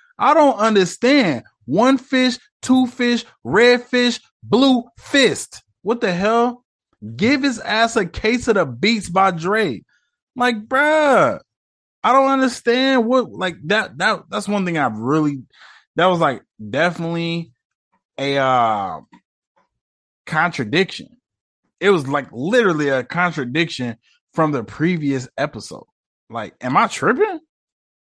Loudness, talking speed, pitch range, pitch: -18 LUFS, 125 wpm, 165-255 Hz, 220 Hz